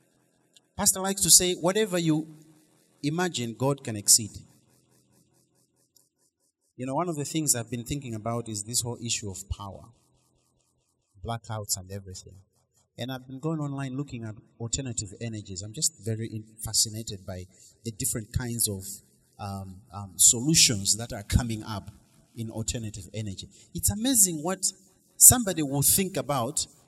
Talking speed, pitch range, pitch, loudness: 145 wpm, 105-145 Hz, 115 Hz, -24 LUFS